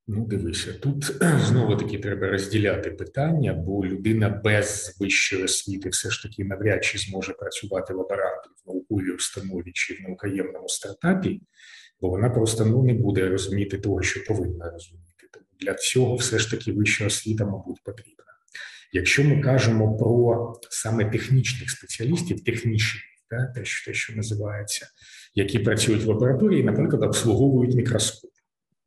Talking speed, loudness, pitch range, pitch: 145 wpm, -24 LUFS, 100-125 Hz, 110 Hz